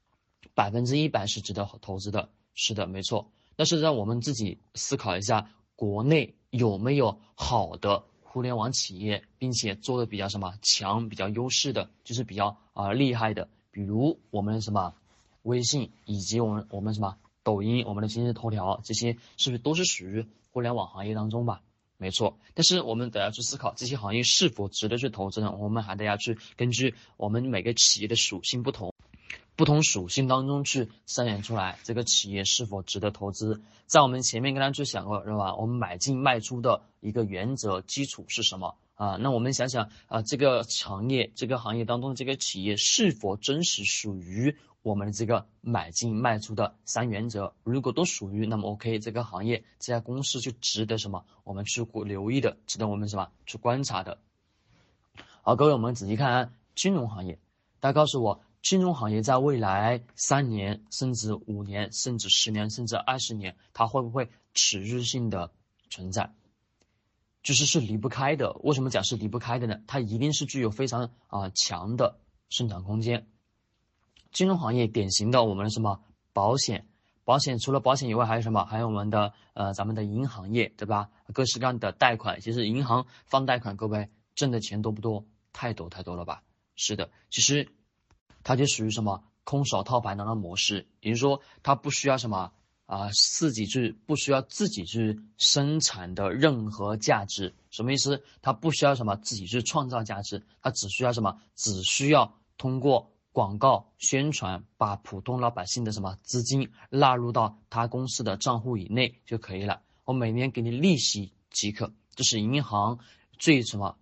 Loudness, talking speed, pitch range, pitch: -27 LUFS, 285 characters per minute, 105-125 Hz, 115 Hz